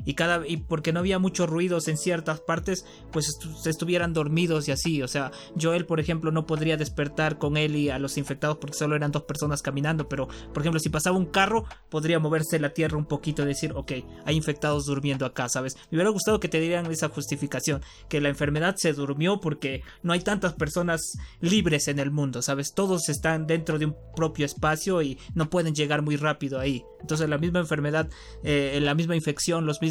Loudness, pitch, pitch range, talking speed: -27 LUFS, 155 Hz, 145-165 Hz, 215 wpm